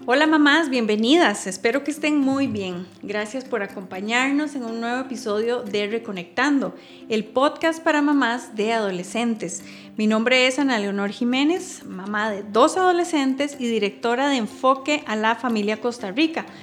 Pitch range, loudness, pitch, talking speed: 210-285 Hz, -22 LUFS, 240 Hz, 150 wpm